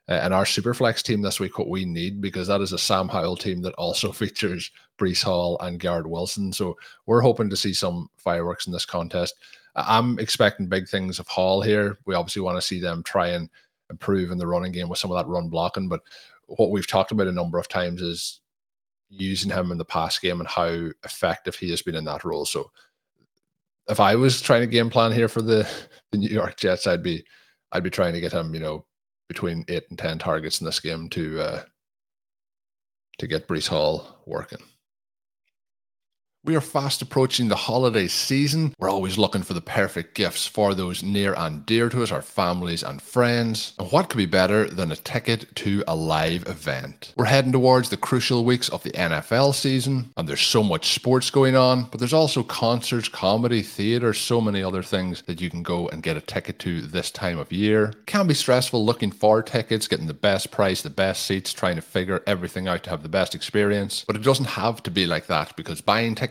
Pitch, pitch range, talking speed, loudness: 100 Hz, 90-120 Hz, 215 wpm, -23 LUFS